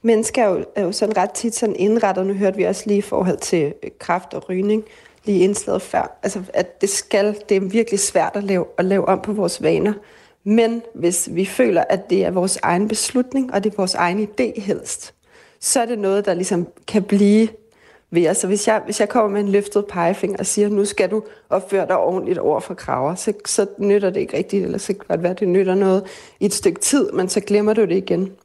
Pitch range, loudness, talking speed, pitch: 190-220 Hz, -19 LUFS, 240 wpm, 205 Hz